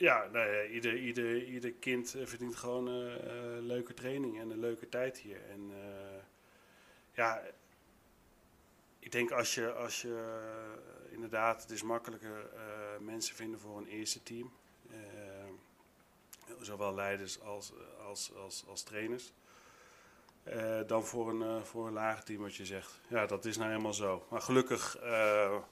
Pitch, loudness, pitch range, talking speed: 110 Hz, -38 LUFS, 105-120 Hz, 155 wpm